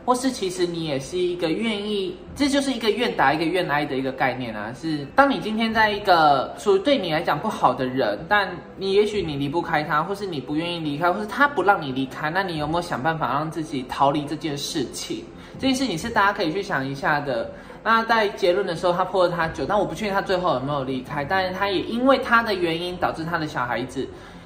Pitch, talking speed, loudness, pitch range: 180 Hz, 355 characters per minute, -23 LUFS, 150-205 Hz